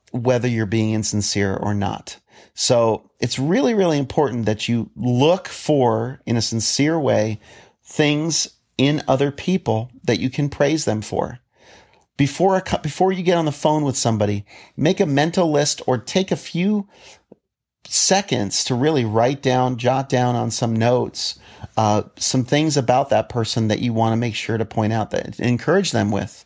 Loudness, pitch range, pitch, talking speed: -20 LUFS, 110-150 Hz, 125 Hz, 170 wpm